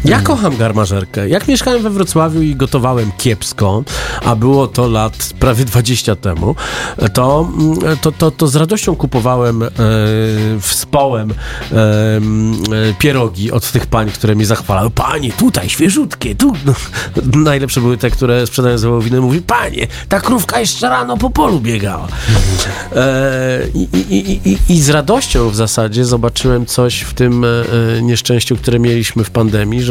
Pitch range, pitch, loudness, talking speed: 110-135 Hz, 120 Hz, -13 LUFS, 145 wpm